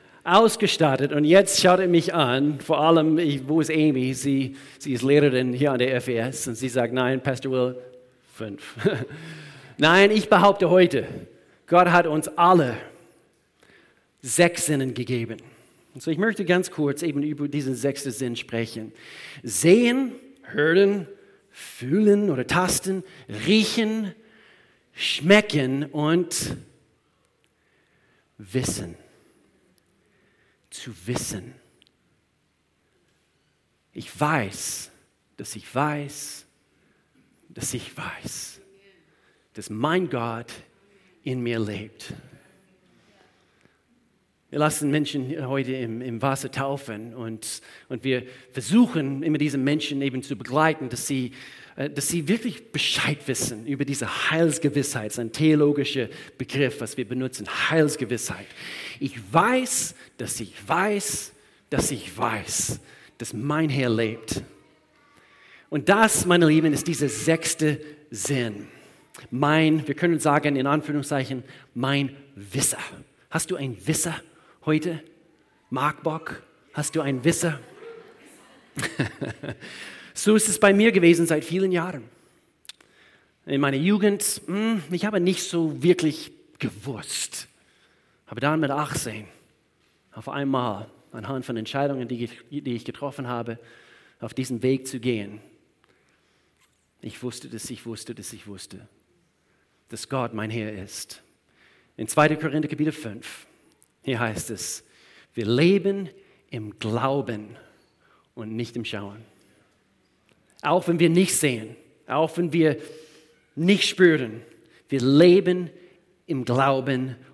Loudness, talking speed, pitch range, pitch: -23 LUFS, 120 wpm, 125-165 Hz, 140 Hz